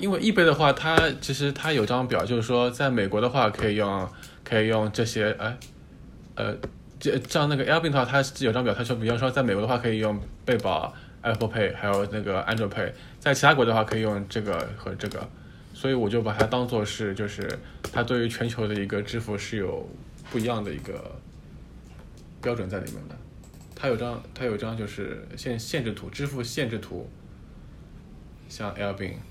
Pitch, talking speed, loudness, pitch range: 110 Hz, 315 characters per minute, -26 LUFS, 105-125 Hz